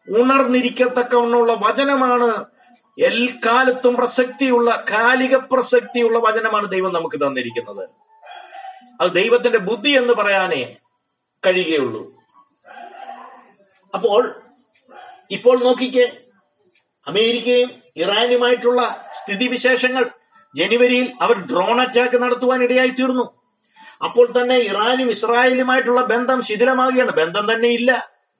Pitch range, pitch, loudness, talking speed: 235-260 Hz, 250 Hz, -17 LUFS, 80 wpm